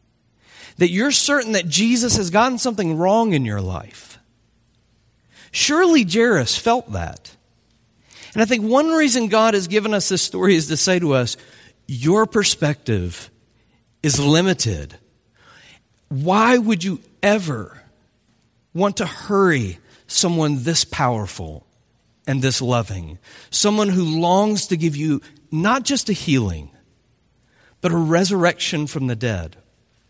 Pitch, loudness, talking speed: 155 Hz, -18 LUFS, 130 wpm